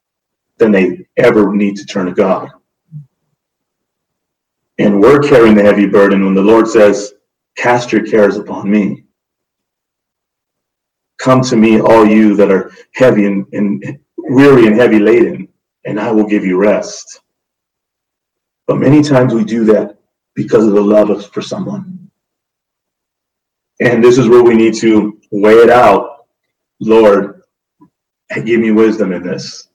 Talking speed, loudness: 145 wpm, -9 LUFS